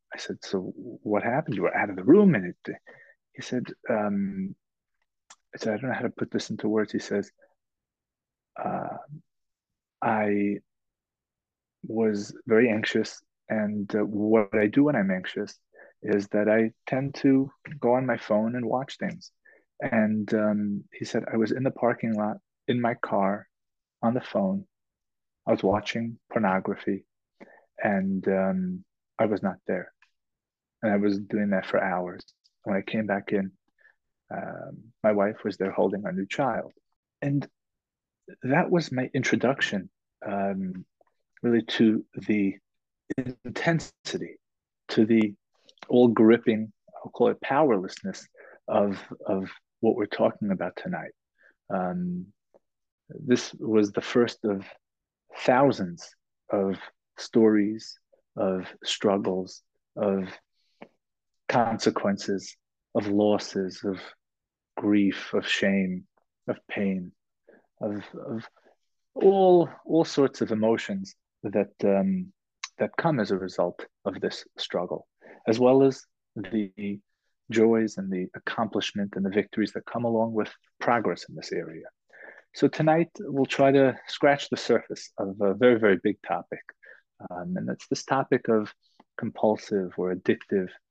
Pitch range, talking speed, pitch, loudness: 100-125 Hz, 135 wpm, 105 Hz, -26 LUFS